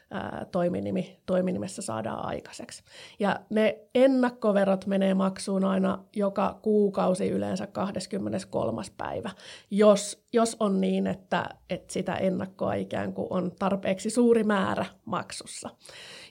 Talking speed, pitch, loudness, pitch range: 105 wpm, 195 Hz, -27 LUFS, 185-215 Hz